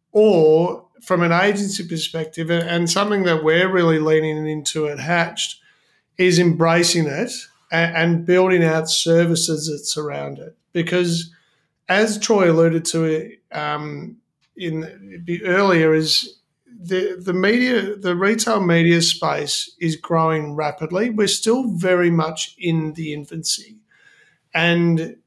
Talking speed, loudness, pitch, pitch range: 125 wpm, -18 LUFS, 170 Hz, 160-195 Hz